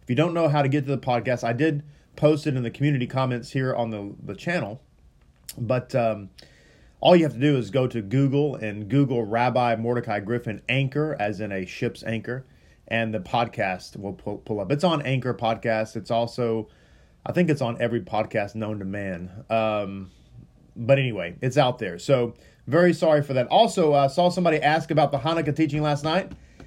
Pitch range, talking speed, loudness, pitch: 110-145 Hz, 200 wpm, -24 LUFS, 120 Hz